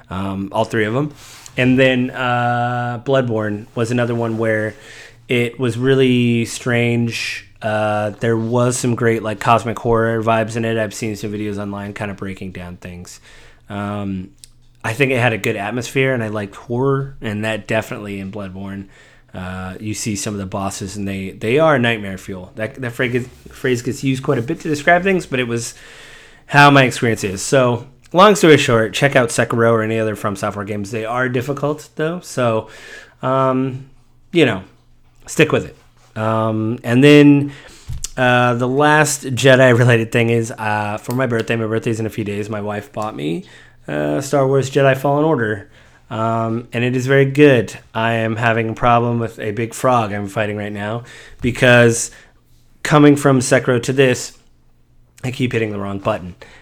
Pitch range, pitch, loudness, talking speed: 105-130 Hz, 115 Hz, -17 LUFS, 180 wpm